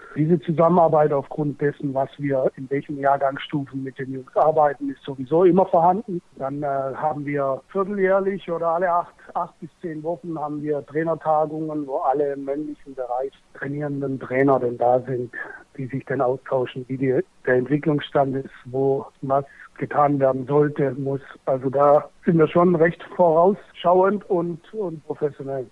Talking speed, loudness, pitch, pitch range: 155 wpm, -22 LUFS, 145 Hz, 135-165 Hz